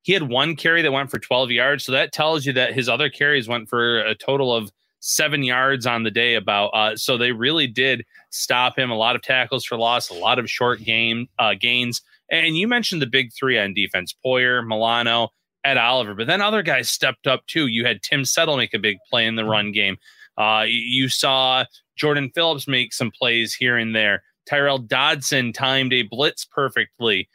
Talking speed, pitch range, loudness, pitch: 210 wpm, 115-140 Hz, -19 LUFS, 125 Hz